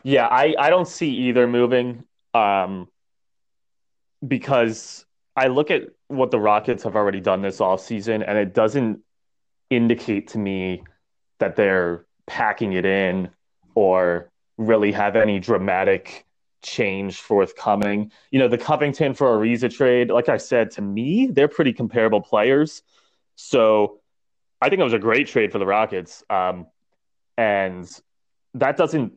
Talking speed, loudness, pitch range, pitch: 145 wpm, -20 LUFS, 95-125 Hz, 105 Hz